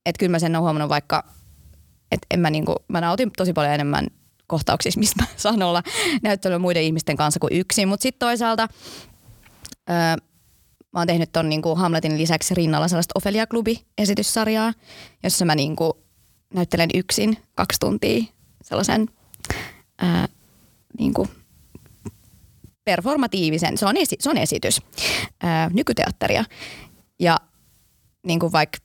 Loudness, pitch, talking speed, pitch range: -21 LUFS, 170 Hz, 130 wpm, 155-210 Hz